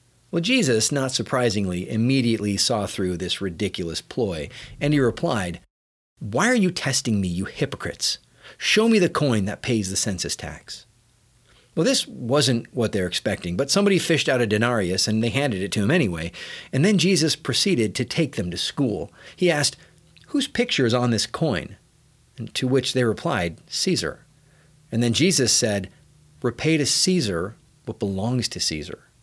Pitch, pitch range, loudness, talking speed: 120 Hz, 105-150 Hz, -22 LUFS, 170 wpm